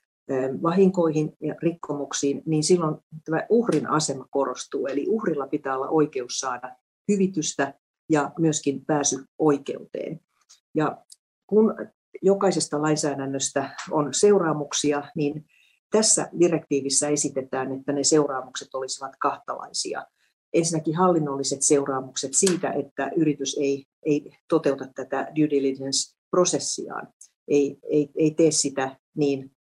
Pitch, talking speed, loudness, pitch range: 145 Hz, 105 wpm, -24 LUFS, 135-160 Hz